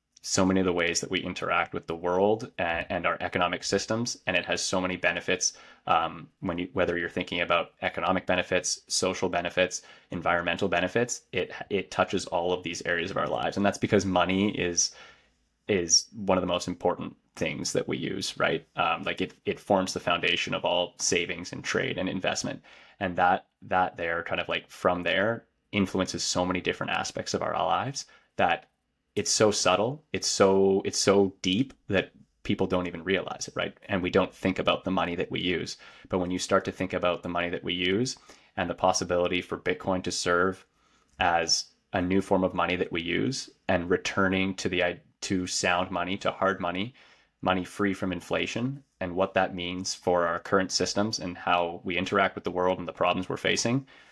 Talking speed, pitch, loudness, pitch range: 200 wpm, 90 Hz, -27 LUFS, 90-95 Hz